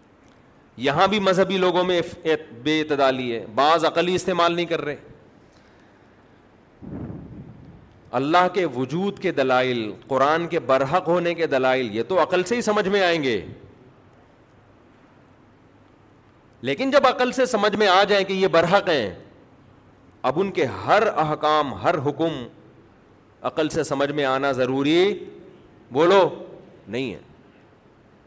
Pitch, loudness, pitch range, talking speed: 155 Hz, -21 LUFS, 130-180 Hz, 130 wpm